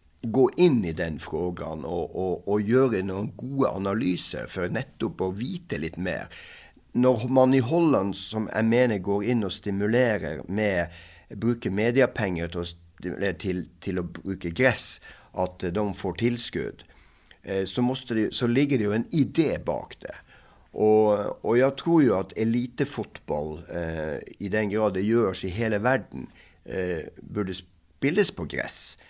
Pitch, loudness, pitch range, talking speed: 105 Hz, -26 LUFS, 90-120 Hz, 140 wpm